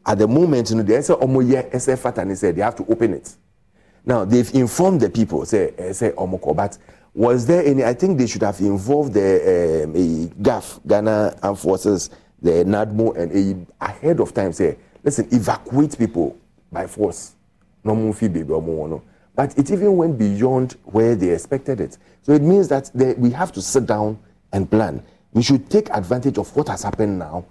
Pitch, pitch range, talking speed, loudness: 115 Hz, 100-135 Hz, 185 wpm, -19 LUFS